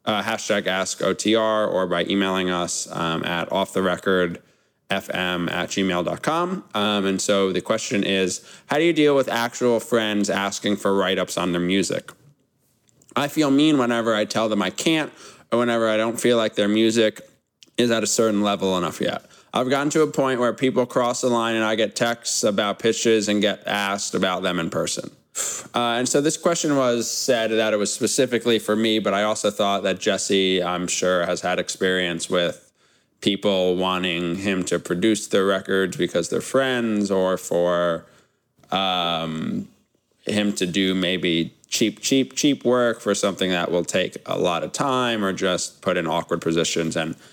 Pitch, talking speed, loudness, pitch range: 105 Hz, 185 wpm, -22 LUFS, 95-120 Hz